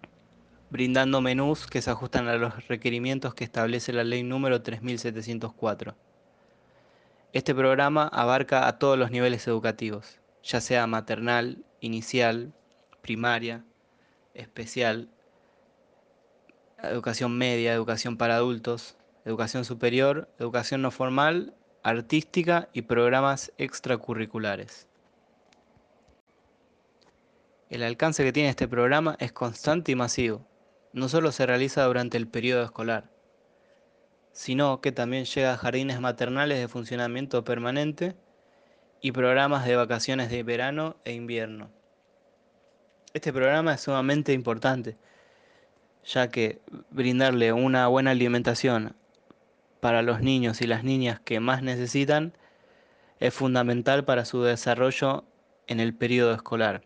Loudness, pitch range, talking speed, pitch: -26 LUFS, 120-135 Hz, 115 wpm, 125 Hz